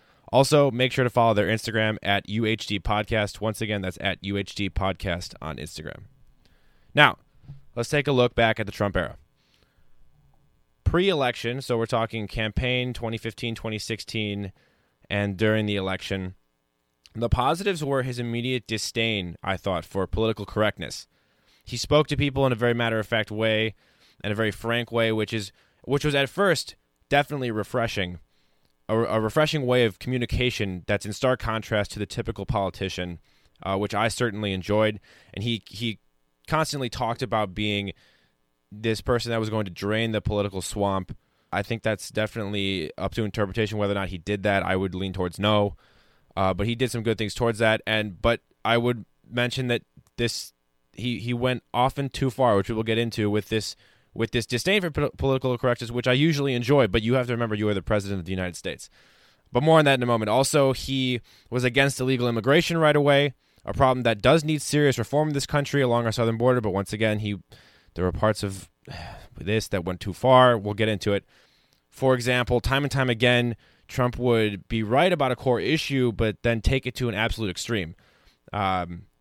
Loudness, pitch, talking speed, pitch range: -25 LUFS, 110 Hz, 185 wpm, 100-125 Hz